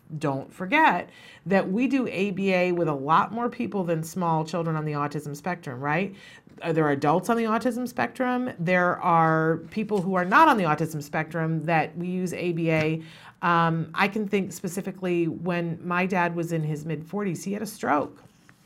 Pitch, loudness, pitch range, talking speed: 175 Hz, -25 LUFS, 160-195 Hz, 185 wpm